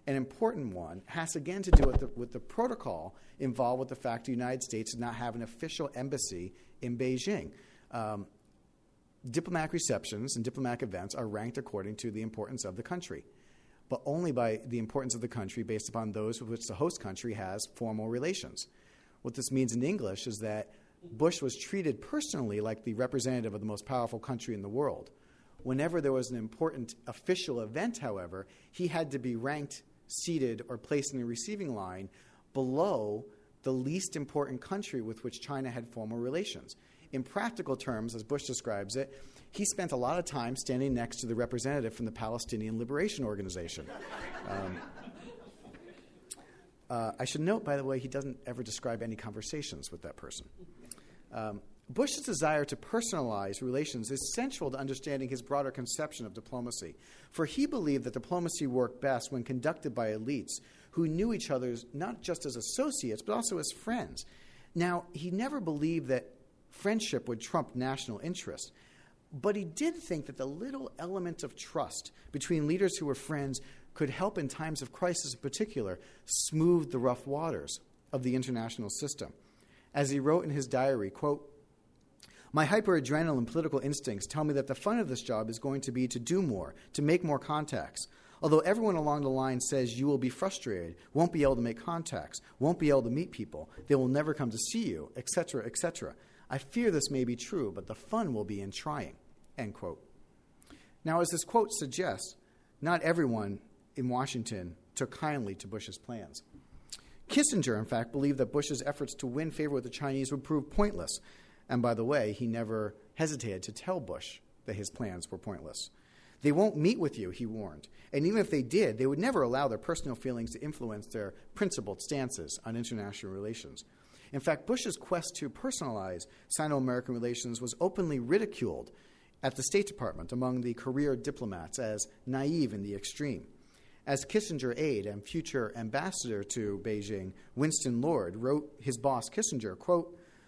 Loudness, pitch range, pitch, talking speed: -34 LUFS, 115-155 Hz, 130 Hz, 180 wpm